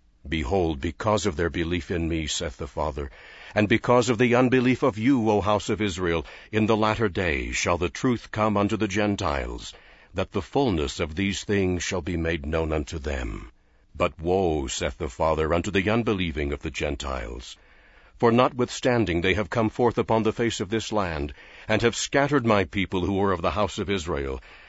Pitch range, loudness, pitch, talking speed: 80-110 Hz, -25 LUFS, 100 Hz, 190 wpm